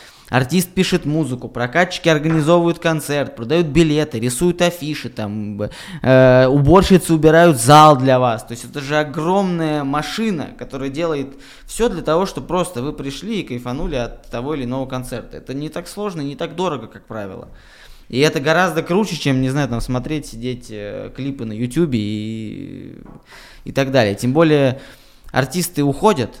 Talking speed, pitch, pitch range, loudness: 160 wpm, 145 Hz, 125-165 Hz, -17 LUFS